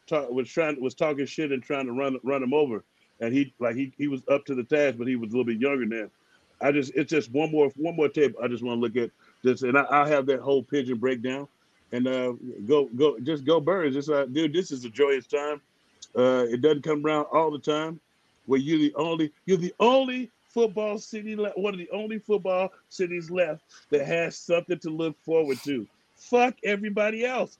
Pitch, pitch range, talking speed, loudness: 145 Hz, 130-170 Hz, 230 wpm, -26 LUFS